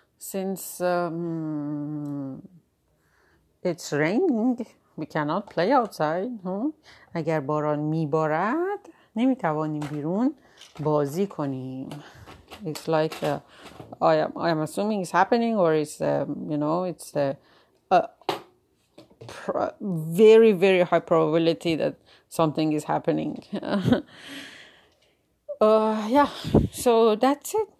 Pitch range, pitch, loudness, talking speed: 155-225 Hz, 170 Hz, -24 LUFS, 100 wpm